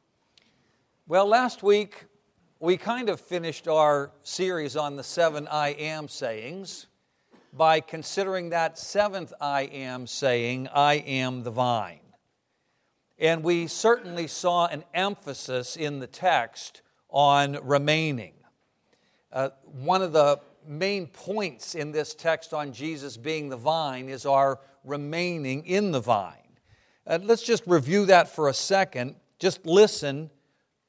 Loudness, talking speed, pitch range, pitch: -26 LUFS, 130 wpm, 140-175 Hz, 155 Hz